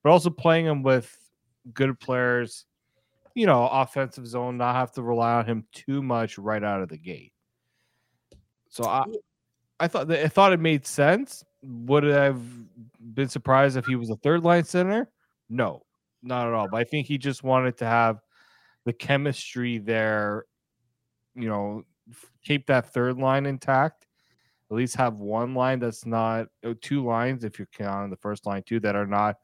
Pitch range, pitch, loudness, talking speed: 115-135 Hz, 125 Hz, -25 LUFS, 175 wpm